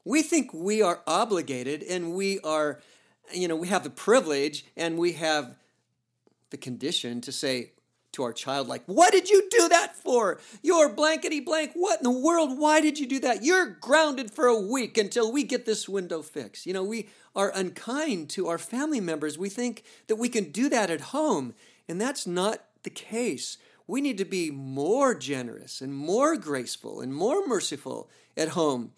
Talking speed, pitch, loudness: 190 wpm, 215 Hz, -26 LUFS